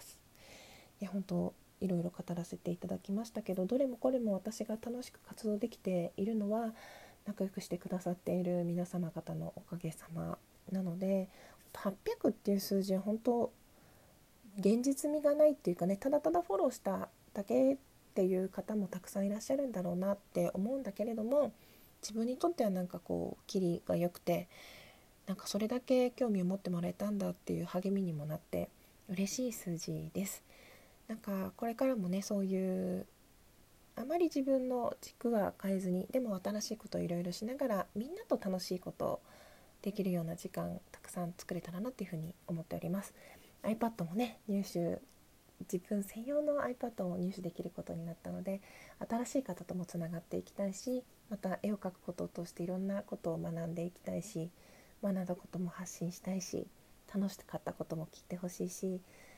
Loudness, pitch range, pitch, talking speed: -38 LUFS, 180-225 Hz, 195 Hz, 365 characters per minute